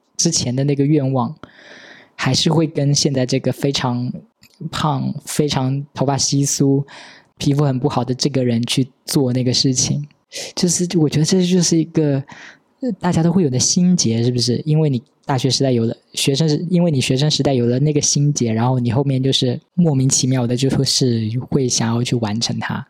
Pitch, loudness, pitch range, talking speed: 140 Hz, -17 LUFS, 125-155 Hz, 280 characters per minute